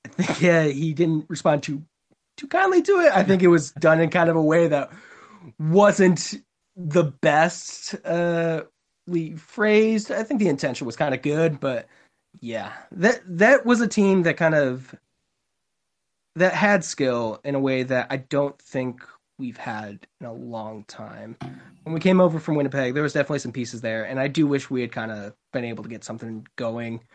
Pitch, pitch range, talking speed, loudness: 160 Hz, 130-180 Hz, 195 wpm, -22 LUFS